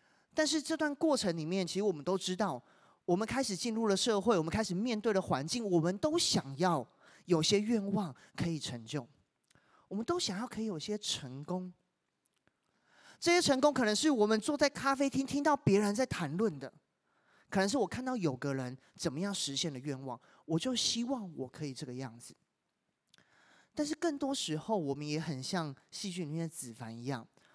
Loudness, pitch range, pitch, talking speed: -34 LUFS, 155-235 Hz, 190 Hz, 275 characters per minute